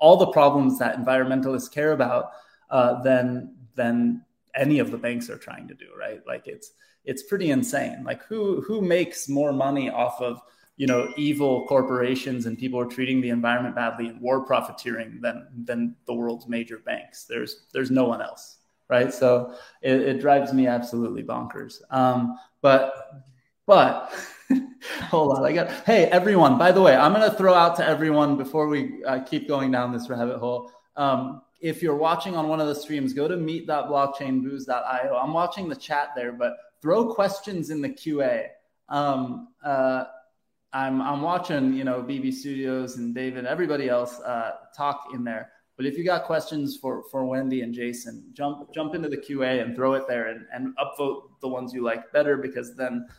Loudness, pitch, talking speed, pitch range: -24 LUFS, 135 Hz, 185 wpm, 125-150 Hz